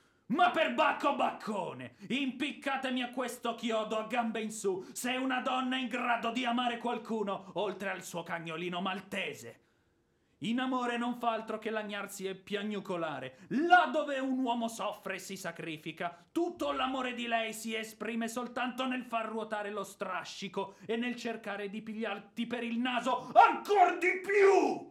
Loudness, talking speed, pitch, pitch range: -33 LUFS, 160 wpm, 230 Hz, 200-255 Hz